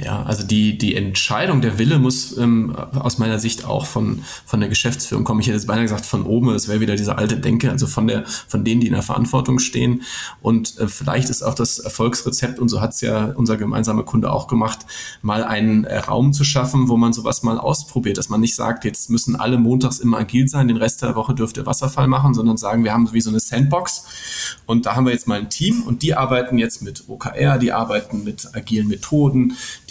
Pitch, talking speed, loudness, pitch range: 120 Hz, 230 wpm, -18 LUFS, 110-130 Hz